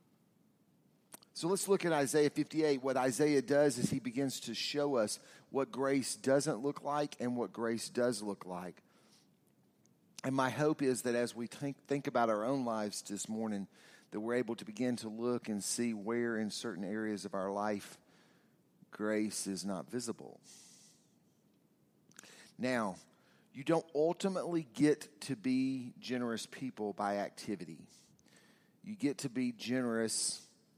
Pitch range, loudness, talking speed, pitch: 110-140 Hz, -36 LUFS, 150 wpm, 125 Hz